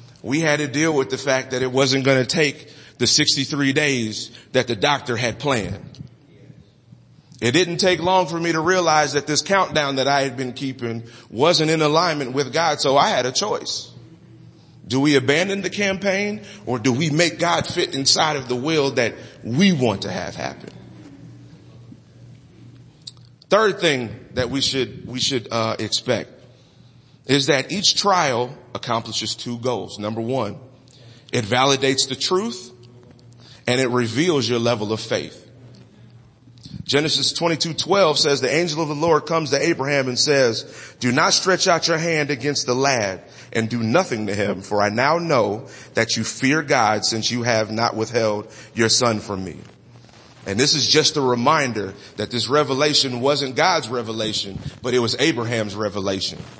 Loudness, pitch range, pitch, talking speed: -20 LUFS, 120-150 Hz, 130 Hz, 170 wpm